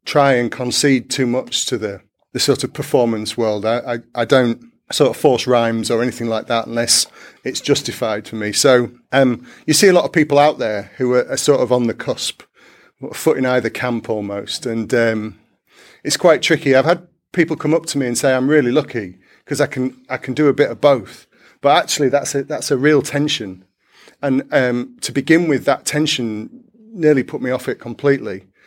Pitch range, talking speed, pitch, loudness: 120-145 Hz, 210 wpm, 130 Hz, -17 LUFS